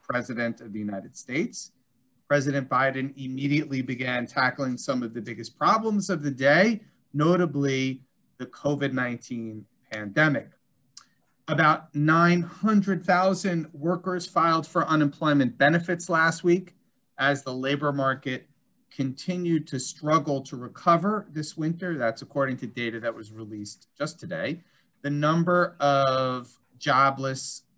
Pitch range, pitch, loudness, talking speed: 125-165 Hz, 140 Hz, -25 LUFS, 120 wpm